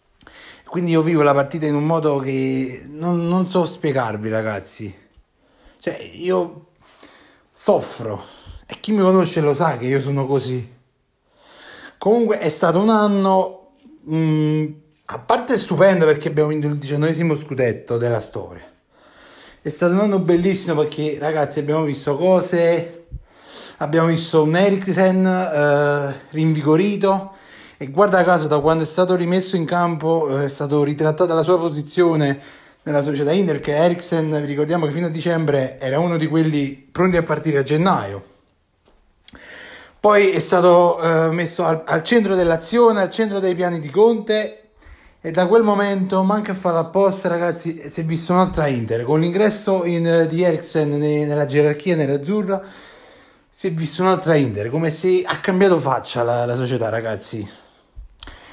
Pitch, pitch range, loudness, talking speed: 160 Hz, 145-185 Hz, -18 LUFS, 150 wpm